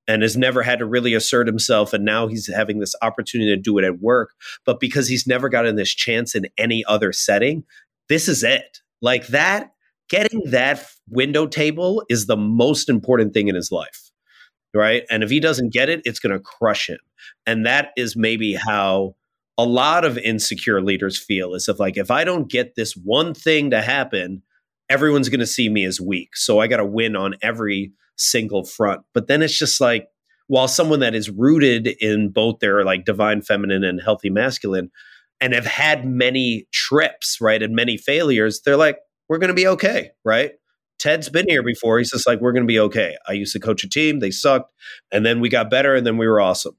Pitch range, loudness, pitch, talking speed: 105-140 Hz, -18 LUFS, 115 Hz, 210 wpm